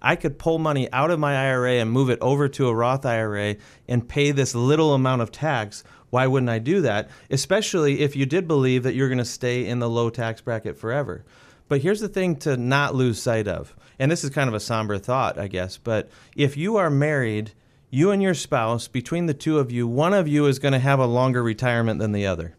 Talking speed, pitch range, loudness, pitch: 240 wpm, 115-145 Hz, -22 LUFS, 130 Hz